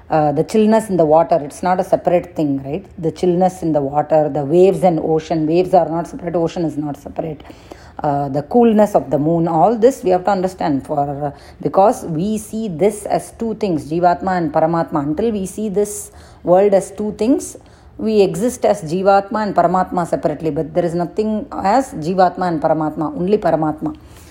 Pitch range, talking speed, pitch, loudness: 155-200 Hz, 195 wpm, 175 Hz, -17 LUFS